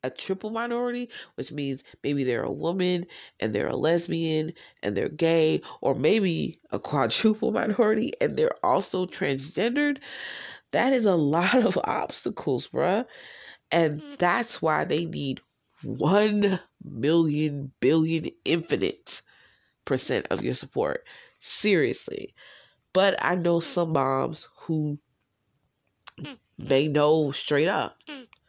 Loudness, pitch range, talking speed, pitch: -26 LUFS, 150-220 Hz, 120 wpm, 170 Hz